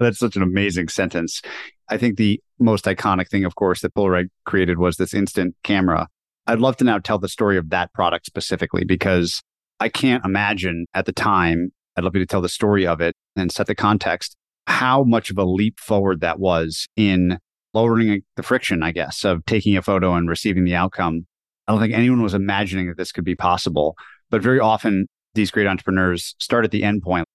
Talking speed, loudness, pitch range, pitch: 210 wpm, -20 LUFS, 90-105 Hz, 95 Hz